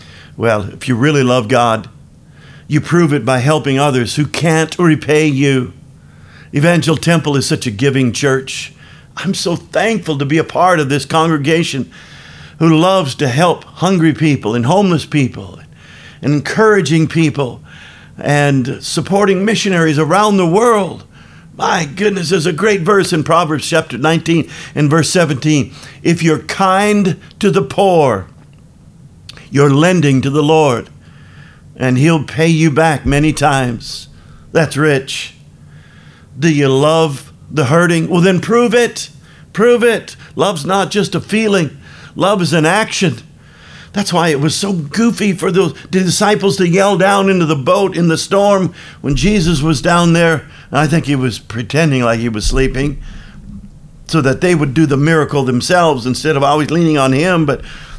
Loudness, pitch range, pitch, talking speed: -13 LUFS, 140-180 Hz, 160 Hz, 155 wpm